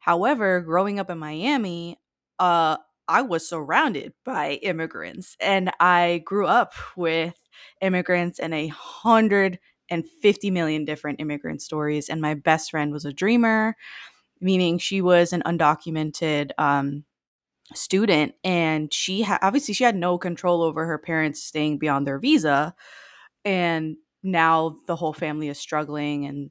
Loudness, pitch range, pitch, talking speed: -23 LUFS, 155-190 Hz, 170 Hz, 140 wpm